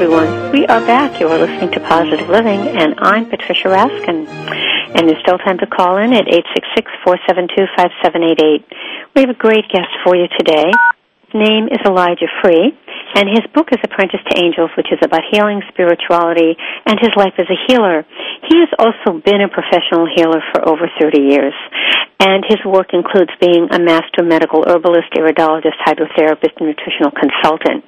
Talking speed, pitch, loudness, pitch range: 170 wpm, 180 Hz, -12 LUFS, 165-205 Hz